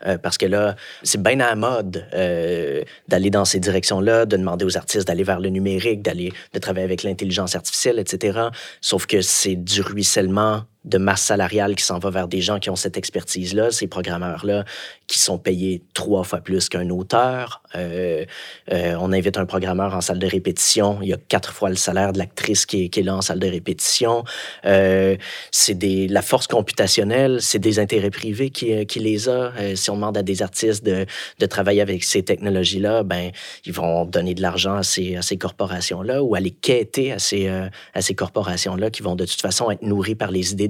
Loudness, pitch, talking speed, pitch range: -20 LUFS, 95 Hz, 210 wpm, 95-105 Hz